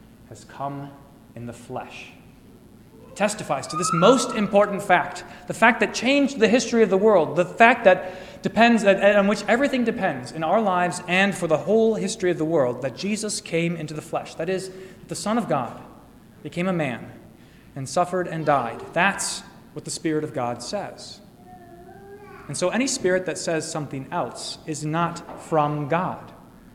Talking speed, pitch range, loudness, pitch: 175 wpm, 155-205 Hz, -22 LUFS, 180 Hz